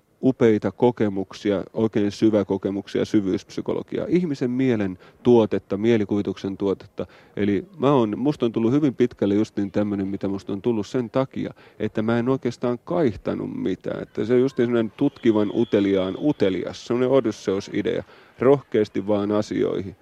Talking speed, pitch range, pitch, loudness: 145 wpm, 100-125 Hz, 110 Hz, -23 LUFS